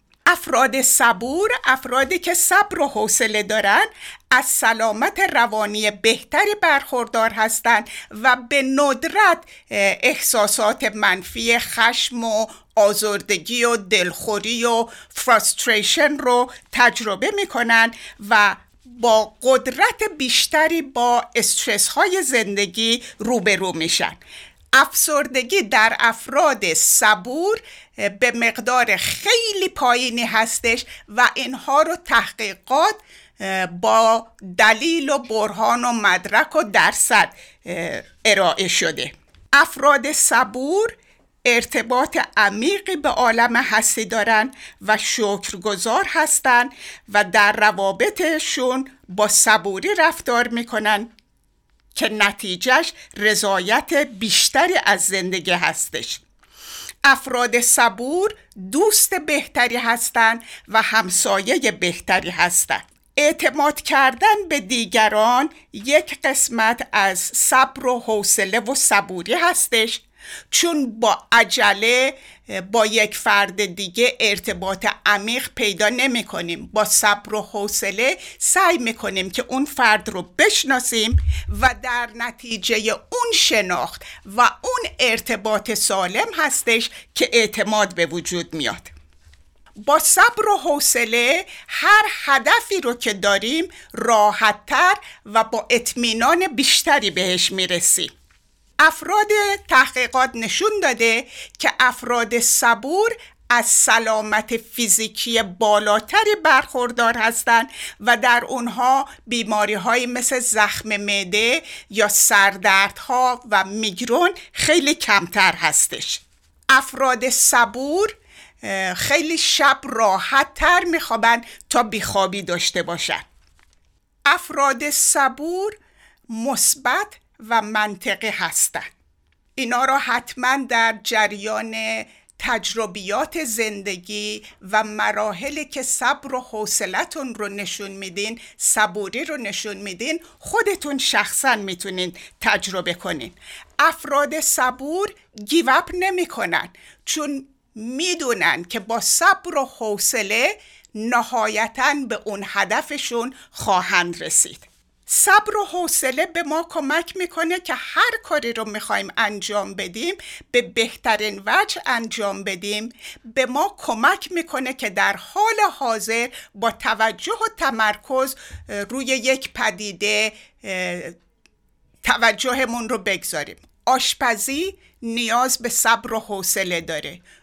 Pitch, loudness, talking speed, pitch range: 235 Hz, -18 LUFS, 100 wpm, 210-285 Hz